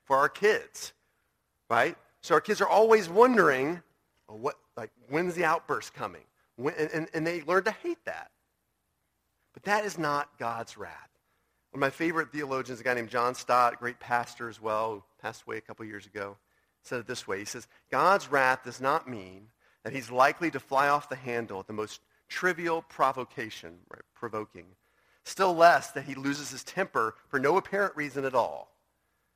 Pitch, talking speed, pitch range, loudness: 135 Hz, 185 wpm, 120-170 Hz, -28 LUFS